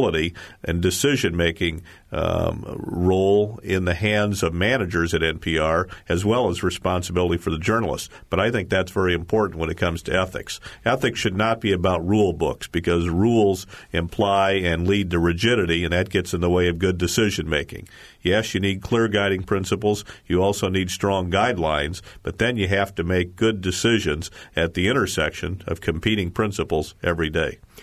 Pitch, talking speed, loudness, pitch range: 95 Hz, 175 wpm, -22 LUFS, 85-100 Hz